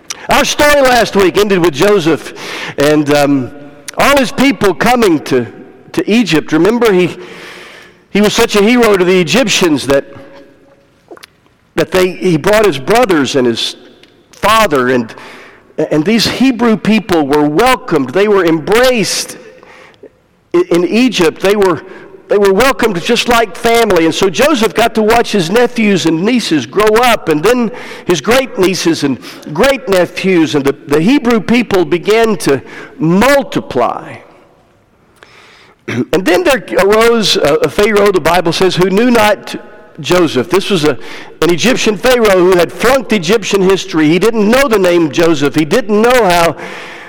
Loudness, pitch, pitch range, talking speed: -10 LUFS, 200 Hz, 170-235 Hz, 155 wpm